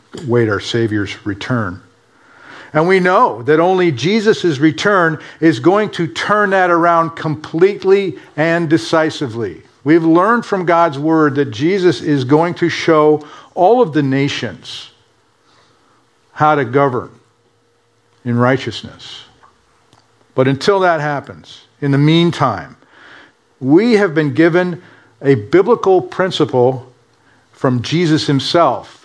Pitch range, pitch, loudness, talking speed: 125-170 Hz, 155 Hz, -14 LUFS, 120 wpm